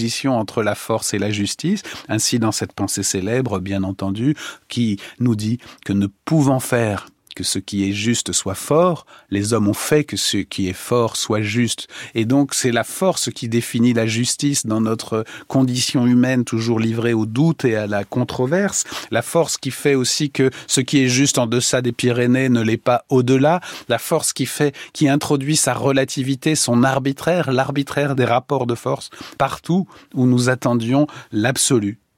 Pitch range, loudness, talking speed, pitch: 110-140 Hz, -19 LUFS, 180 wpm, 125 Hz